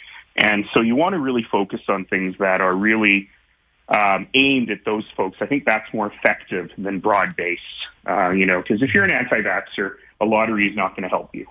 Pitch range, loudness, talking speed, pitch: 95-110 Hz, -19 LUFS, 210 wpm, 105 Hz